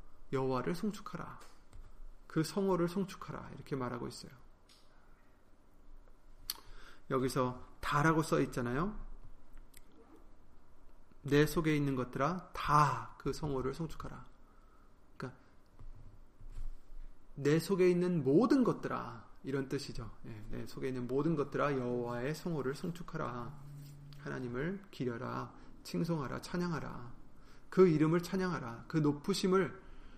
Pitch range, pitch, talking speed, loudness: 125-165 Hz, 145 Hz, 240 characters per minute, -35 LUFS